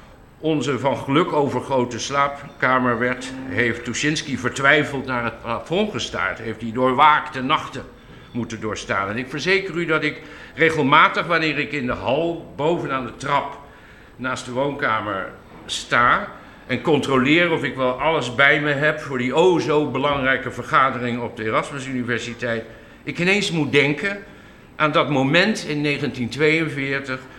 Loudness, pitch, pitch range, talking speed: -20 LUFS, 135 Hz, 125-150 Hz, 150 wpm